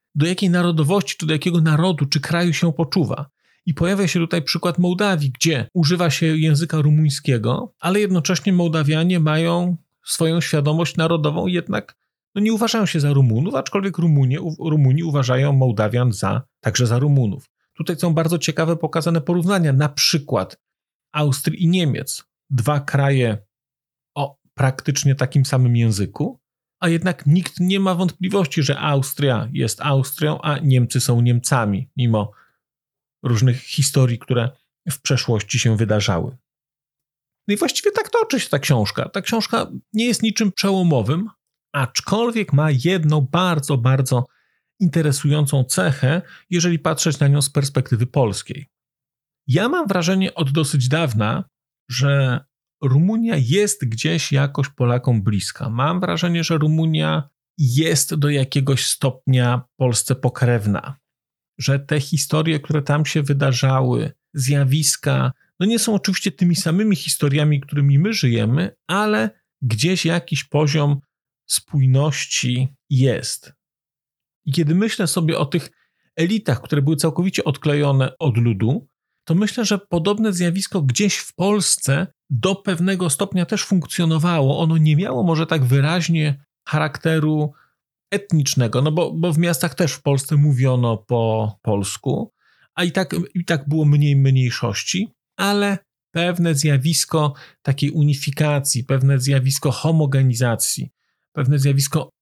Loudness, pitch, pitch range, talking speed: -19 LUFS, 150 Hz, 135-170 Hz, 130 wpm